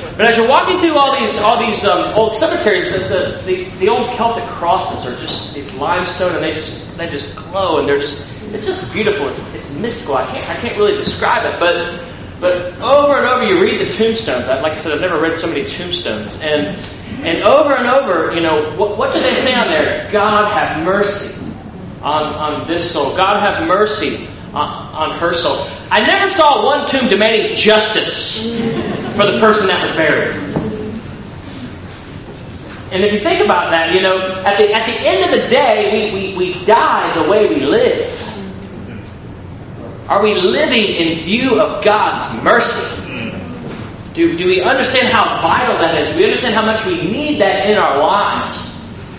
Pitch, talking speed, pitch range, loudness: 215 Hz, 190 wpm, 180-285 Hz, -14 LUFS